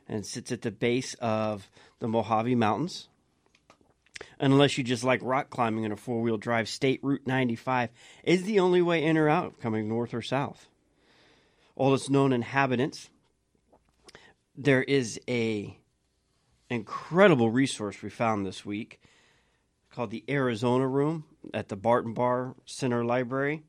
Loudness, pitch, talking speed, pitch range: -28 LUFS, 125 Hz, 140 wpm, 115-140 Hz